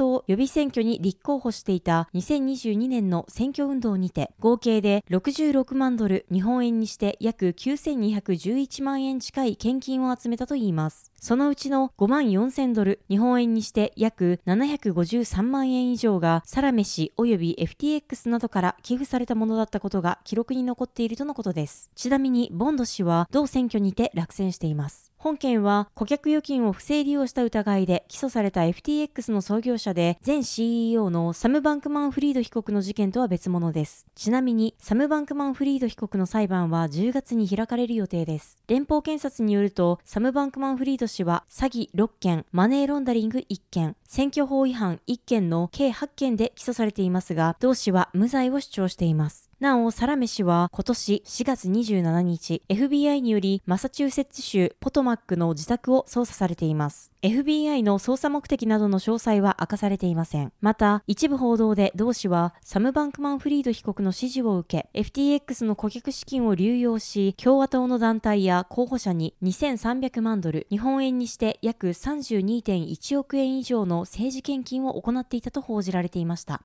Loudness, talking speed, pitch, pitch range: -25 LUFS, 330 characters per minute, 230 Hz, 190-265 Hz